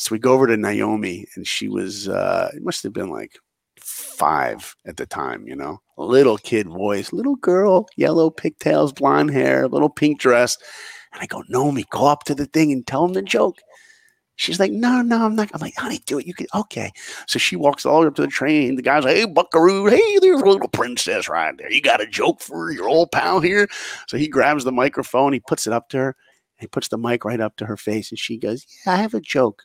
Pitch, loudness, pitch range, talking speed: 150 Hz, -19 LUFS, 125-200 Hz, 245 wpm